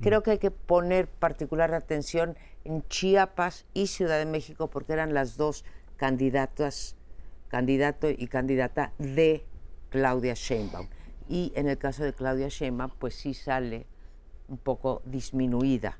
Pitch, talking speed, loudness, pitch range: 135 Hz, 140 wpm, -29 LUFS, 125-155 Hz